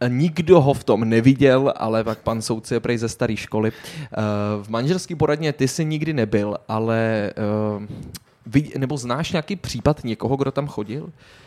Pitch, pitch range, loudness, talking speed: 120 Hz, 110-145 Hz, -21 LUFS, 155 wpm